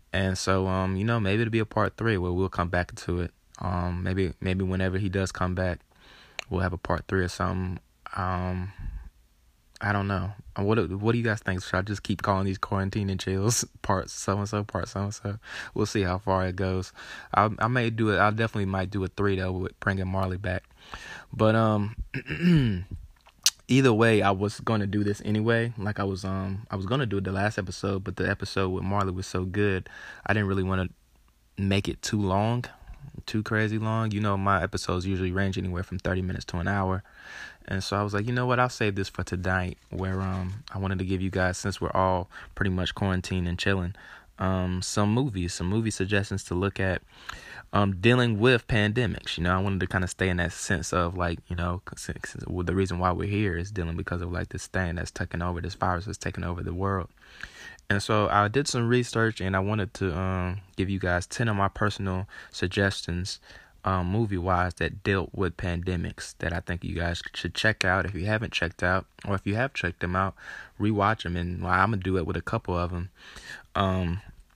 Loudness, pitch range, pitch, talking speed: -28 LUFS, 90-105 Hz, 95 Hz, 225 wpm